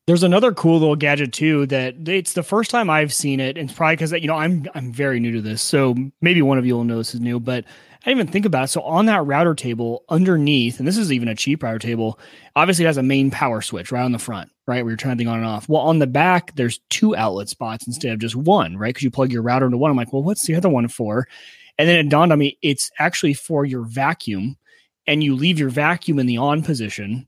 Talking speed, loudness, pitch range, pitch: 275 wpm, -19 LUFS, 120-160 Hz, 140 Hz